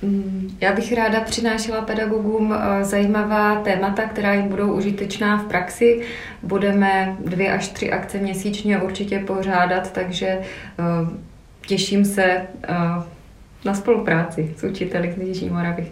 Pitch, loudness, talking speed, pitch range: 195 Hz, -21 LUFS, 115 wpm, 185-210 Hz